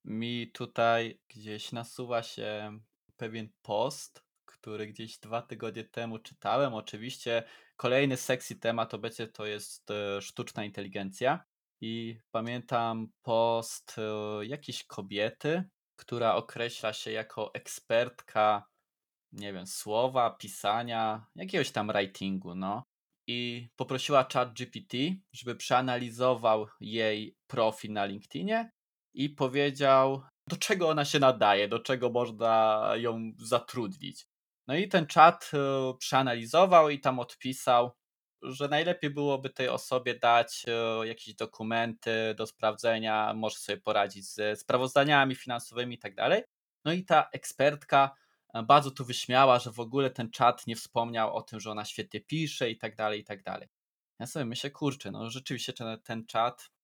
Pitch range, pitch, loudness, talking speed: 110-130 Hz, 115 Hz, -30 LUFS, 130 wpm